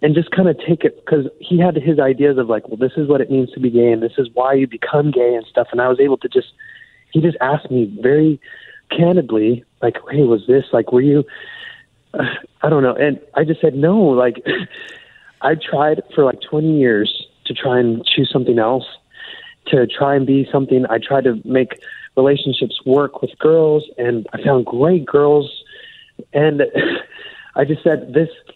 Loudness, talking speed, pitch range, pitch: -16 LUFS, 200 wpm, 130-170 Hz, 145 Hz